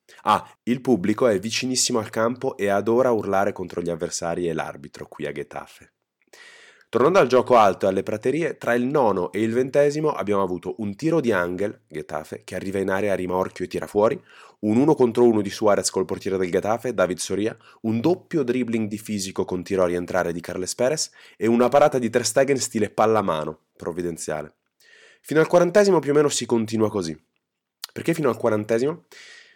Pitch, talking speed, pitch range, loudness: 110 Hz, 190 wpm, 95-125 Hz, -22 LUFS